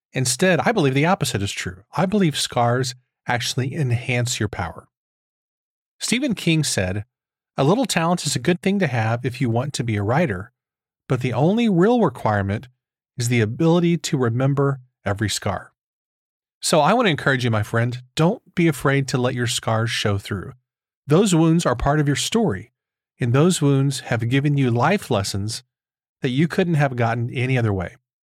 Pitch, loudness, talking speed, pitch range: 130 Hz, -20 LUFS, 180 wpm, 120-160 Hz